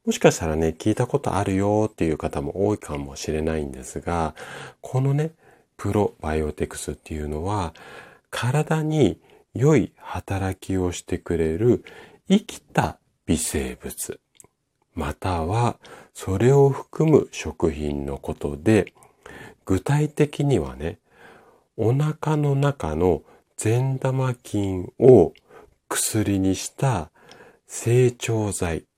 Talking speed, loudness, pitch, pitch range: 215 characters per minute, -23 LUFS, 100 Hz, 80-130 Hz